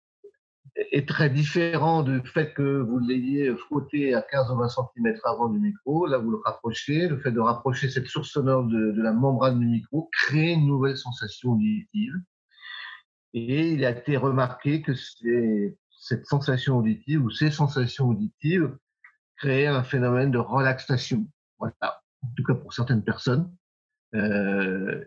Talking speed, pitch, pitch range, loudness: 160 wpm, 135 Hz, 120-150 Hz, -25 LUFS